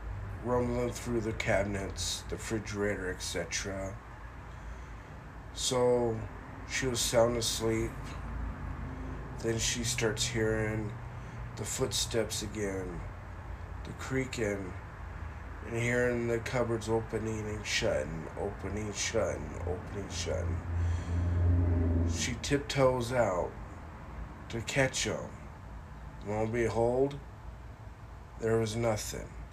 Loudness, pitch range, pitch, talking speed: -33 LUFS, 90-115 Hz, 105 Hz, 90 wpm